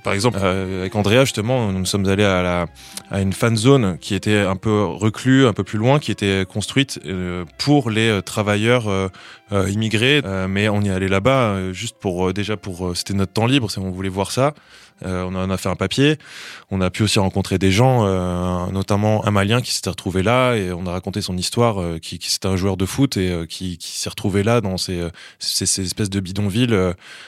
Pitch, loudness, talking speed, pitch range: 100 Hz, -19 LUFS, 215 wpm, 95-110 Hz